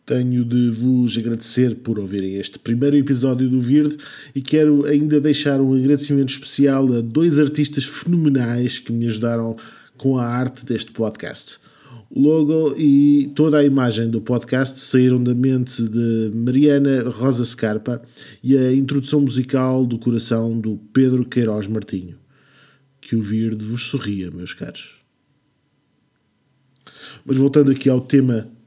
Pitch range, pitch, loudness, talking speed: 115-140 Hz, 130 Hz, -18 LUFS, 140 wpm